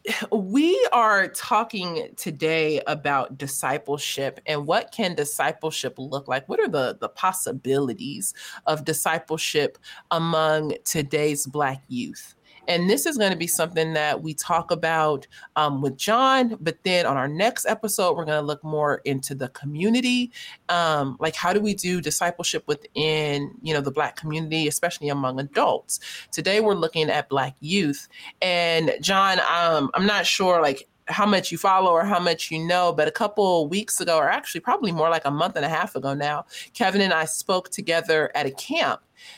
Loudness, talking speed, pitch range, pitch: -23 LUFS, 175 wpm, 150-190 Hz, 160 Hz